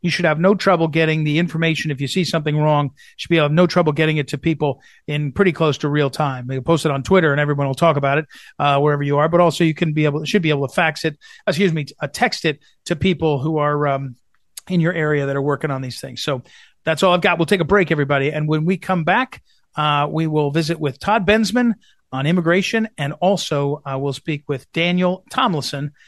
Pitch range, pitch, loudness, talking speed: 145-175 Hz, 155 Hz, -18 LUFS, 255 wpm